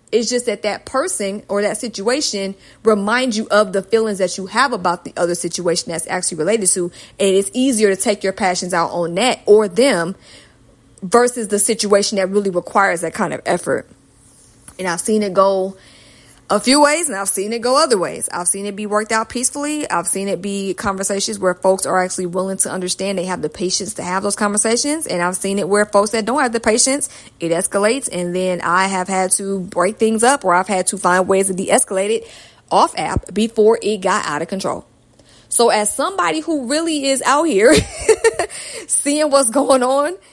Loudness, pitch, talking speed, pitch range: -17 LUFS, 200 Hz, 205 wpm, 185-235 Hz